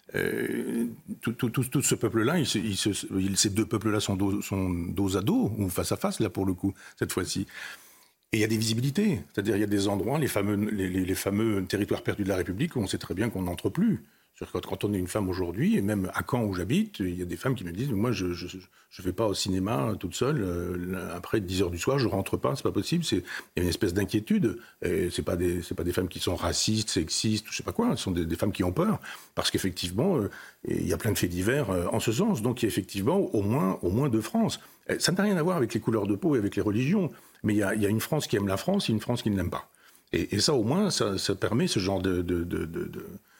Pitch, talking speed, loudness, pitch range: 100 Hz, 285 wpm, -28 LUFS, 95-115 Hz